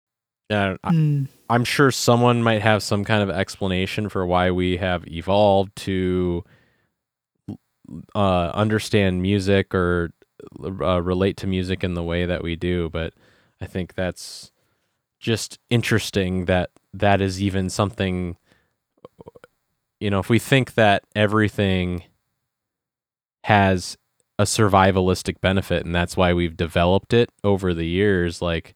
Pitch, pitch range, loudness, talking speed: 95 Hz, 90-105 Hz, -21 LUFS, 130 wpm